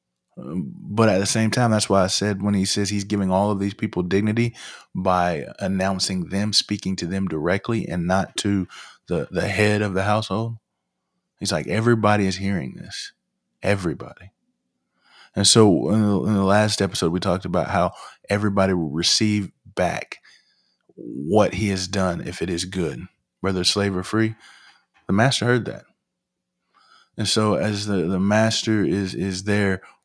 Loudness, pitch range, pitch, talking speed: -21 LUFS, 95-105 Hz, 100 Hz, 165 wpm